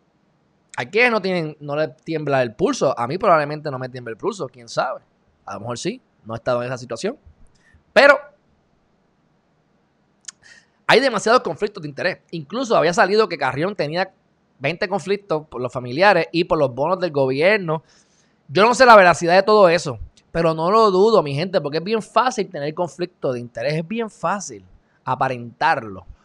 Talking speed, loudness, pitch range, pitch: 180 wpm, -19 LUFS, 130-195 Hz, 165 Hz